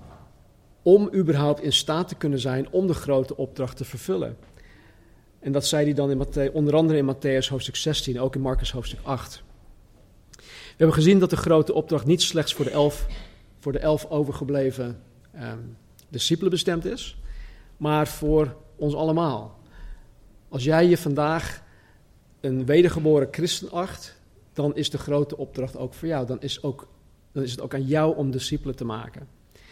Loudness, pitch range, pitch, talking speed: -24 LUFS, 125-155 Hz, 140 Hz, 170 wpm